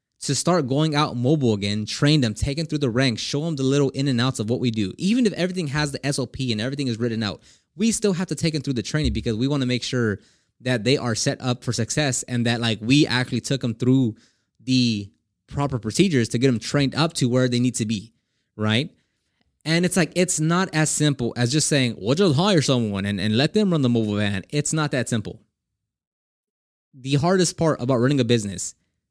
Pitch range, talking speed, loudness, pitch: 115-150 Hz, 235 wpm, -22 LUFS, 130 Hz